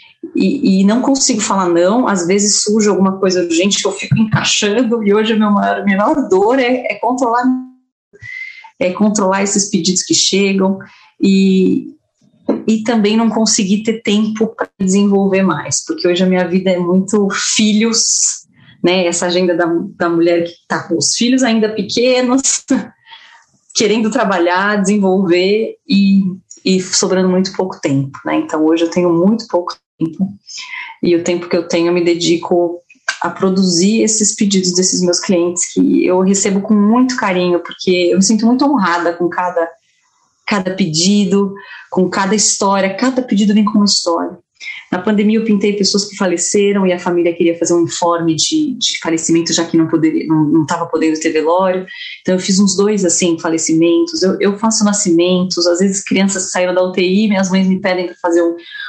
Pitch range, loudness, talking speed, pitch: 175-215 Hz, -13 LUFS, 175 wpm, 195 Hz